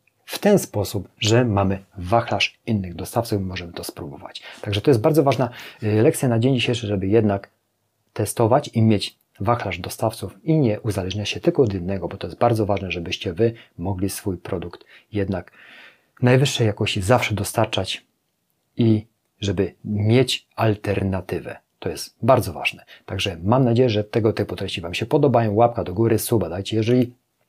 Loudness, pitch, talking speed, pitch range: -21 LUFS, 110 Hz, 160 wpm, 100-120 Hz